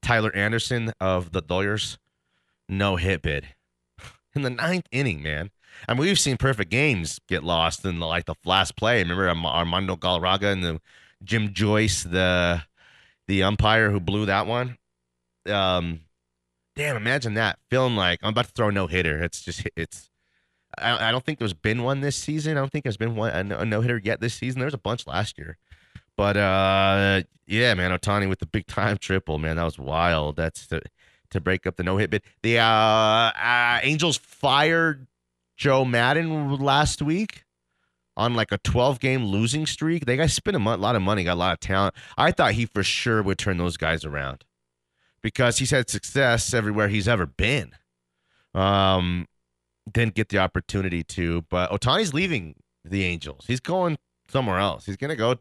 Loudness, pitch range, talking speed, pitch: -23 LUFS, 85-120 Hz, 185 wpm, 100 Hz